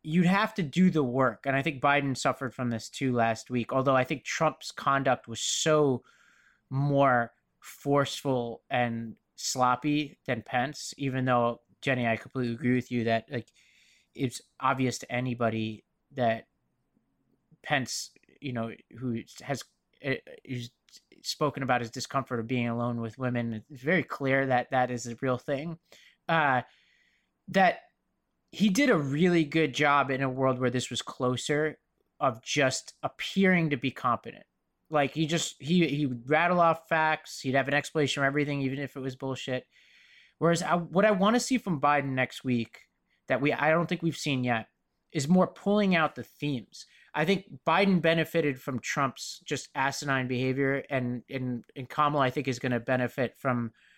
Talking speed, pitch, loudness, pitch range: 170 wpm, 135 Hz, -28 LUFS, 125-155 Hz